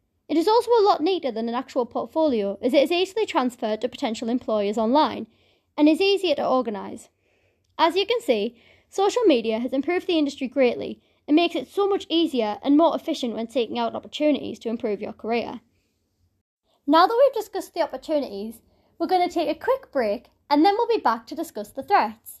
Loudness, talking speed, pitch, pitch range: -23 LUFS, 200 wpm, 290 Hz, 230-350 Hz